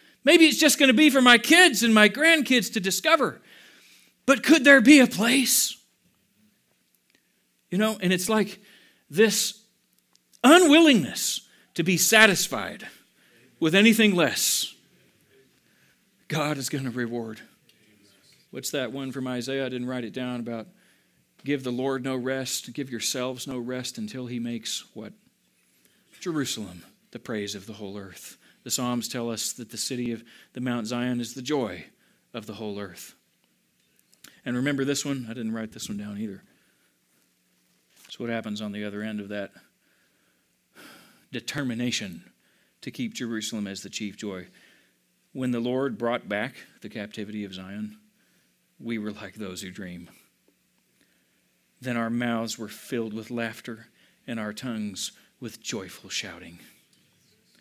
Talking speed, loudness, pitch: 150 wpm, -23 LUFS, 125 Hz